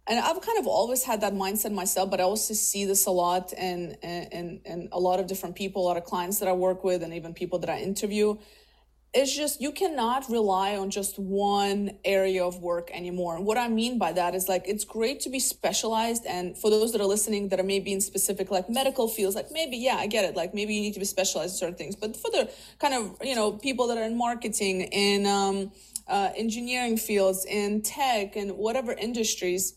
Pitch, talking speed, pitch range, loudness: 200 Hz, 235 wpm, 185-225 Hz, -27 LUFS